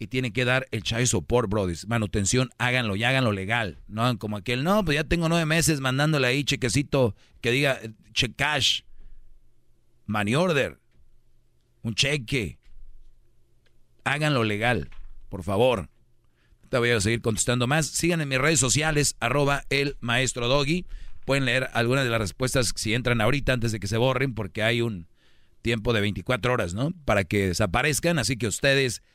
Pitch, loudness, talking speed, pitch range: 125 Hz, -24 LUFS, 165 wpm, 110-135 Hz